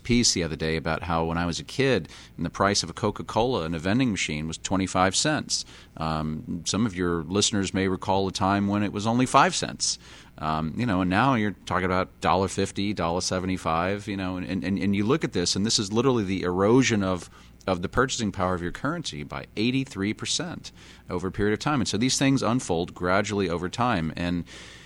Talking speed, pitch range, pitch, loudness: 225 wpm, 85-105 Hz, 95 Hz, -25 LUFS